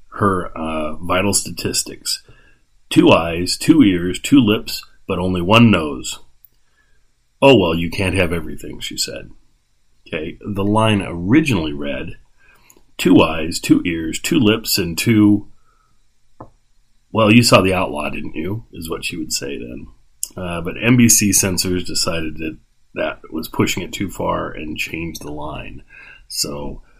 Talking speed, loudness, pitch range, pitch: 145 wpm, -17 LUFS, 80-110 Hz, 95 Hz